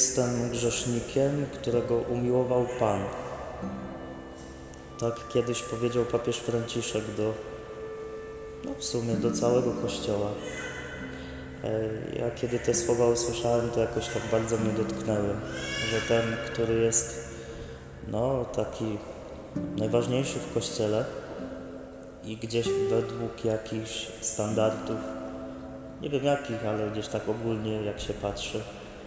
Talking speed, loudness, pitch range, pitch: 105 wpm, -29 LUFS, 105-120 Hz, 115 Hz